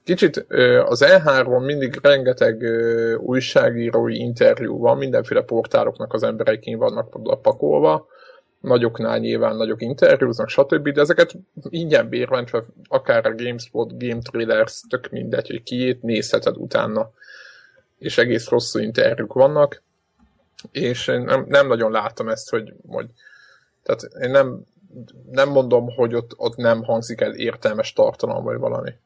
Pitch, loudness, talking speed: 135 Hz, -19 LUFS, 130 wpm